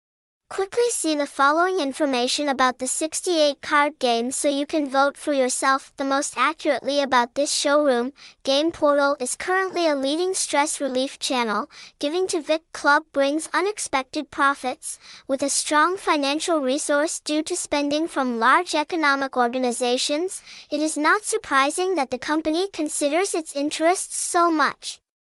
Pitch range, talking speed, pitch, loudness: 275-320 Hz, 145 wpm, 295 Hz, -22 LUFS